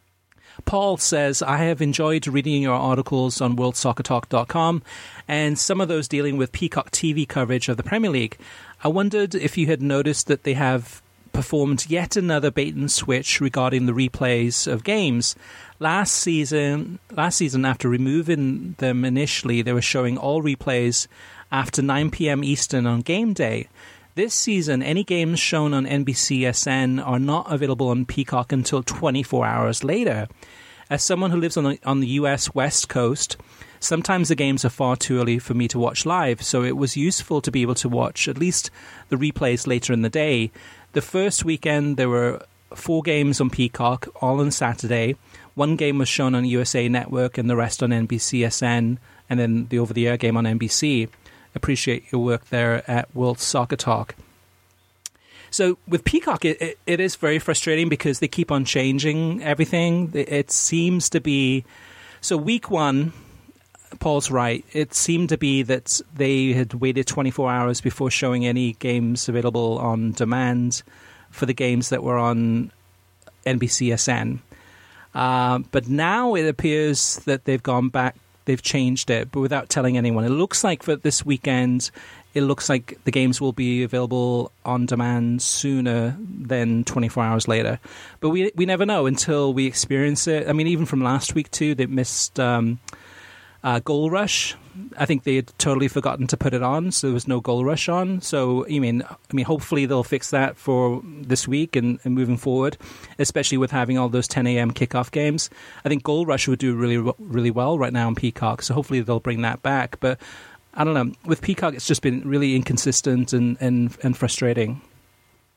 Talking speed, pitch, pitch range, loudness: 180 wpm, 130 Hz, 120-150 Hz, -22 LUFS